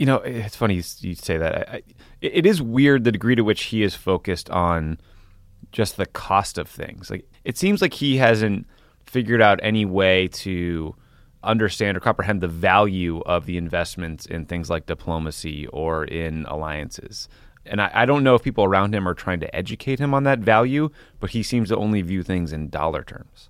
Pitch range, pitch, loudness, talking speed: 85-115 Hz, 95 Hz, -21 LUFS, 195 wpm